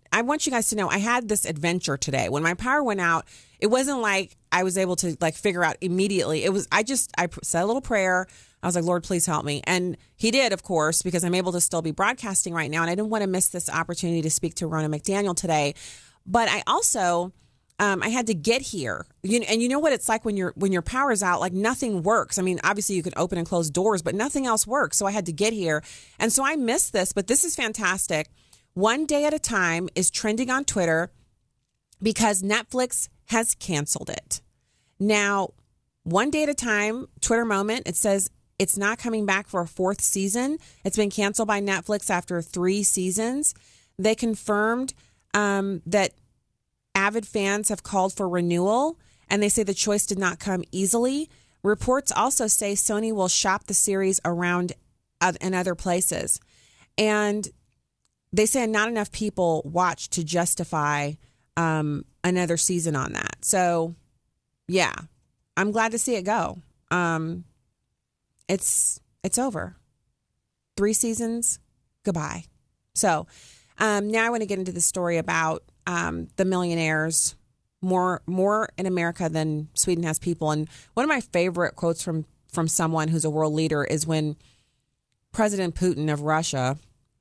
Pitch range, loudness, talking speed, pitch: 165-215 Hz, -24 LUFS, 180 wpm, 185 Hz